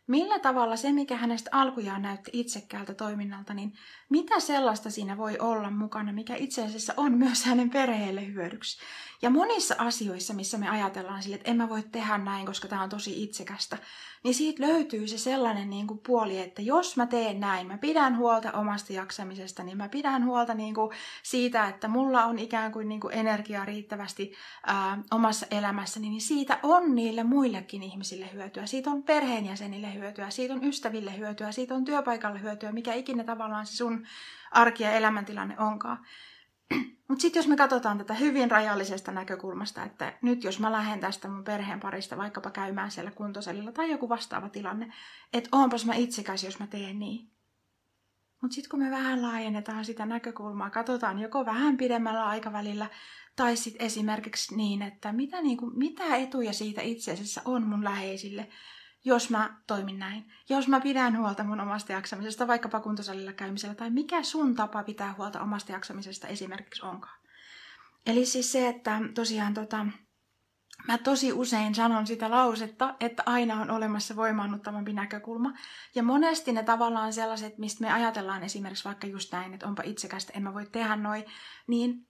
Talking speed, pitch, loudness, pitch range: 165 wpm, 220 Hz, -30 LUFS, 205-245 Hz